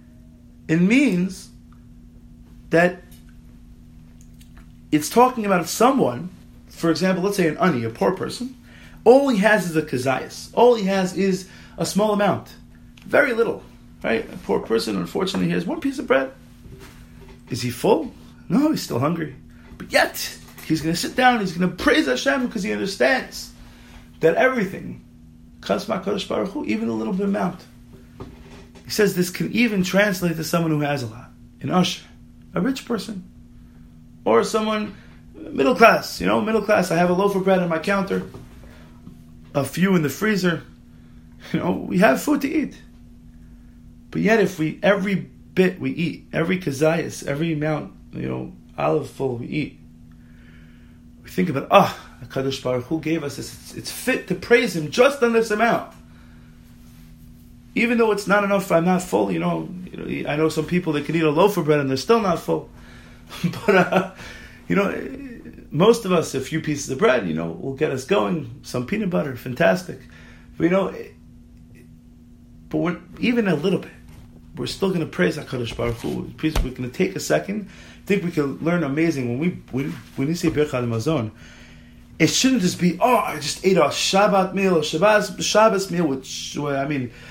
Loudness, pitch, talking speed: -21 LUFS, 160 Hz, 180 wpm